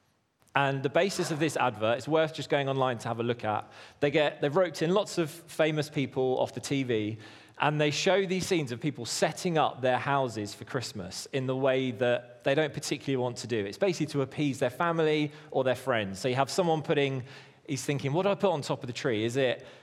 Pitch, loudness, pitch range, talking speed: 140 Hz, -29 LUFS, 125-155 Hz, 235 wpm